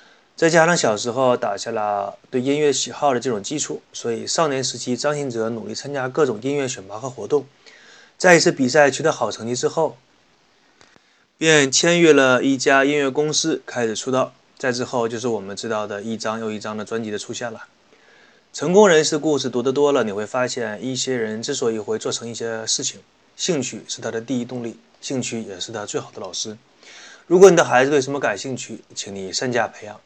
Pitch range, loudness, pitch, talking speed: 115-145 Hz, -20 LUFS, 125 Hz, 305 characters per minute